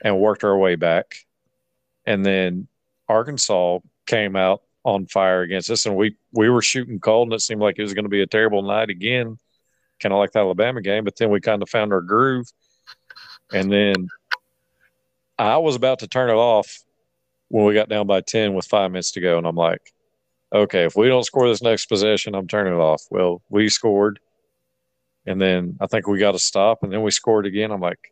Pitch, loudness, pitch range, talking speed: 105 Hz, -19 LUFS, 95-110 Hz, 215 wpm